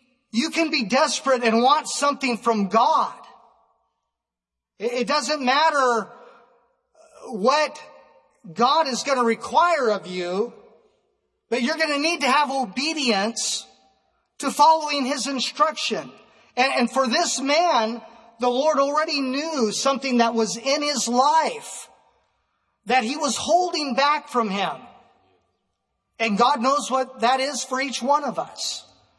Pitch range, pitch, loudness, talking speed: 235-295 Hz, 265 Hz, -21 LUFS, 130 wpm